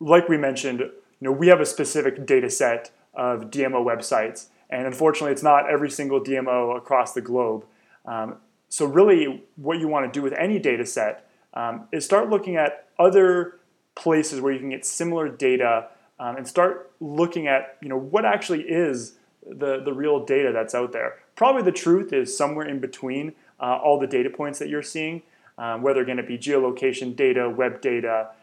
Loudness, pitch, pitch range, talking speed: -23 LUFS, 140 Hz, 125-165 Hz, 195 wpm